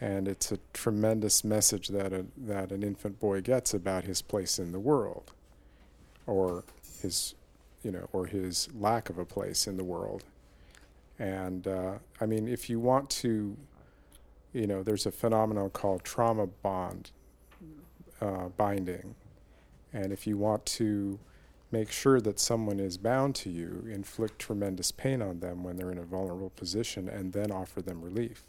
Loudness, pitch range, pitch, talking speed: -32 LUFS, 90-110 Hz, 100 Hz, 165 wpm